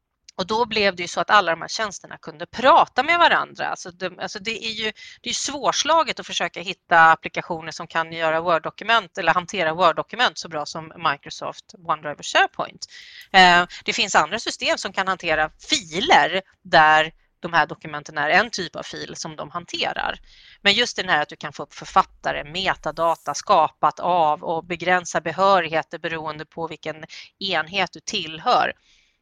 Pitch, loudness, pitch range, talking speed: 175 Hz, -21 LUFS, 160-200 Hz, 175 wpm